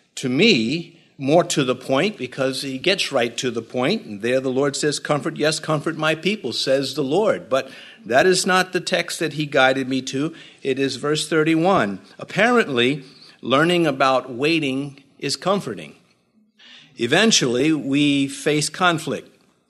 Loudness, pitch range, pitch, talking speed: -20 LUFS, 135-170 Hz, 150 Hz, 155 wpm